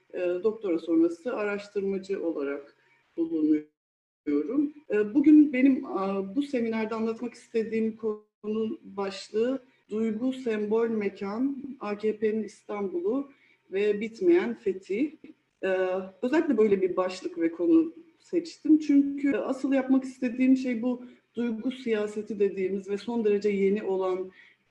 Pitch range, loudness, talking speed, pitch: 200-270 Hz, -28 LUFS, 100 wpm, 225 Hz